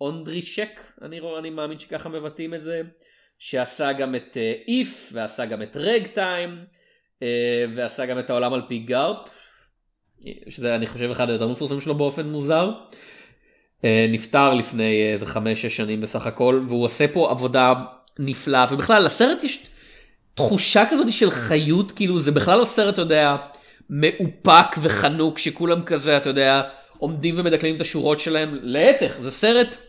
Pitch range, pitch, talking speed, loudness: 125-170 Hz, 150 Hz, 155 wpm, -20 LUFS